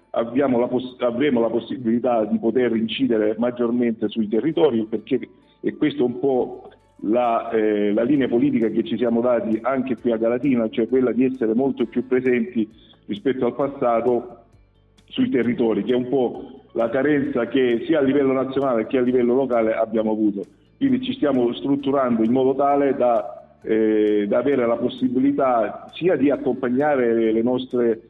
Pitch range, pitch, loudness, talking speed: 115-130 Hz, 120 Hz, -21 LUFS, 165 wpm